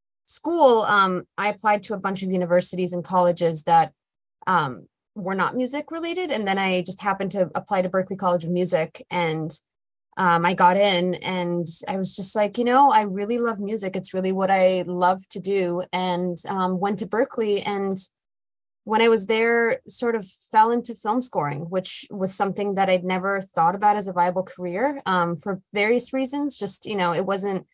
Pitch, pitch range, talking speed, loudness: 195 Hz, 180-215 Hz, 195 wpm, -22 LUFS